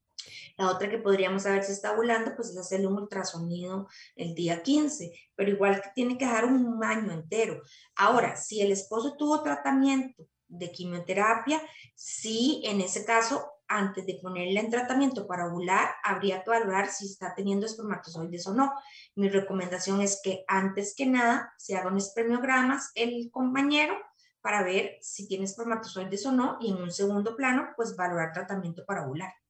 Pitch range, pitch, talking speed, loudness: 190-235 Hz, 200 Hz, 165 wpm, -29 LUFS